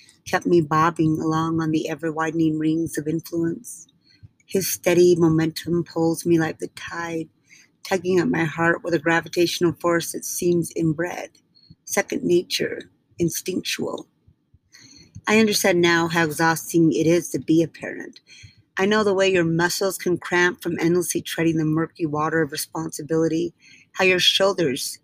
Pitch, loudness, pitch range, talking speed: 165 Hz, -21 LUFS, 160-175 Hz, 150 wpm